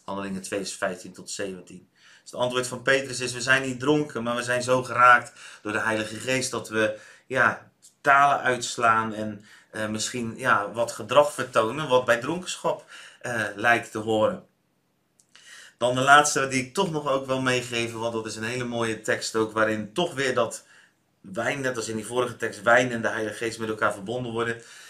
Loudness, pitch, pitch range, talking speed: -24 LUFS, 115 Hz, 110-125 Hz, 195 wpm